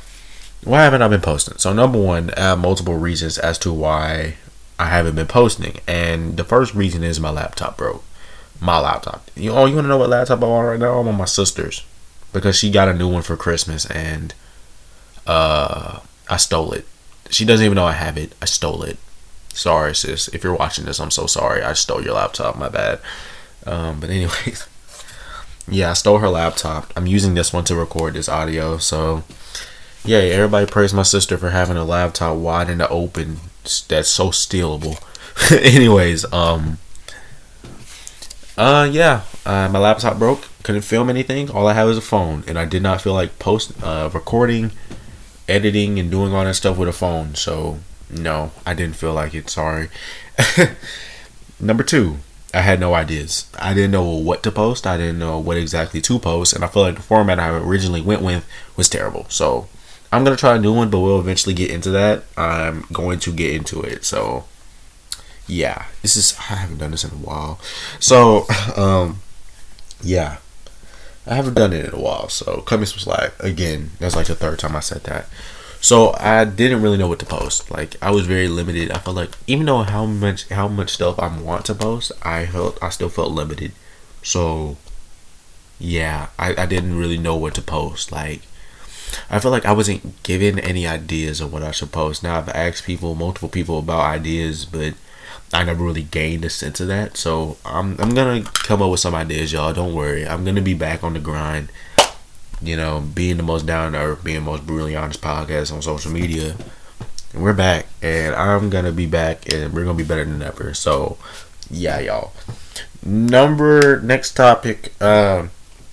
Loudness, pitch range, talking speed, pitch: -17 LUFS, 80-100 Hz, 195 wpm, 85 Hz